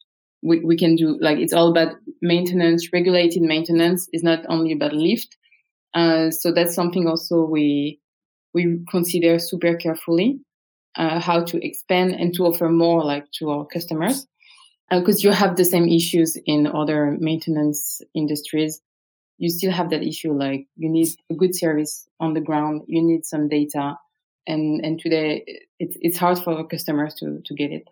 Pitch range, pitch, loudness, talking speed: 155-175 Hz, 165 Hz, -20 LUFS, 170 wpm